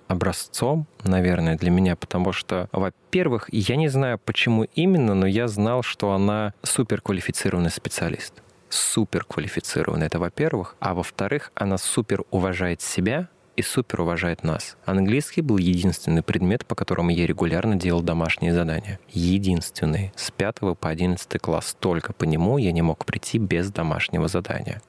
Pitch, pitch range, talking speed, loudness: 95 Hz, 85-110 Hz, 140 wpm, -23 LUFS